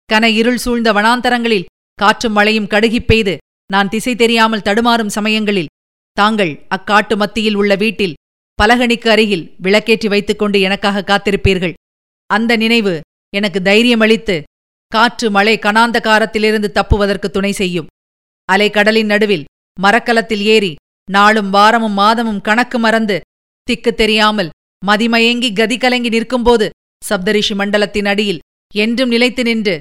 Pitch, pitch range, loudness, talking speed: 215 Hz, 200-225 Hz, -13 LUFS, 110 wpm